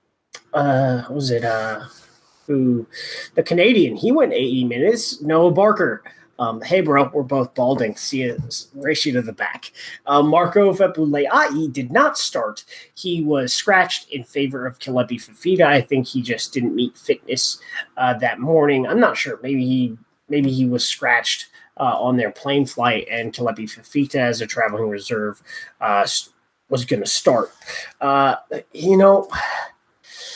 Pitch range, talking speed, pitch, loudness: 125-160 Hz, 155 wpm, 140 Hz, -19 LUFS